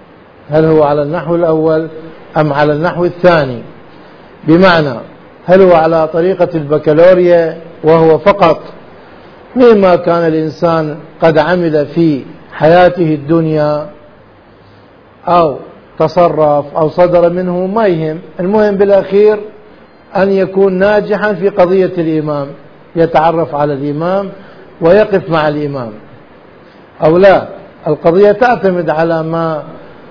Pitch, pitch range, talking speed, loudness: 165 Hz, 155-180 Hz, 105 wpm, -10 LUFS